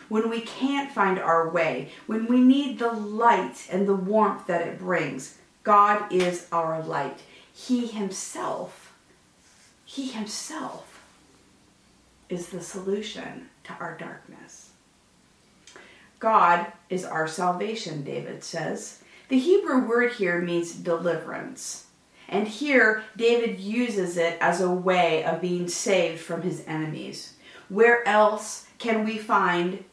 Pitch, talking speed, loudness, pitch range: 195 Hz, 125 wpm, -25 LUFS, 170-225 Hz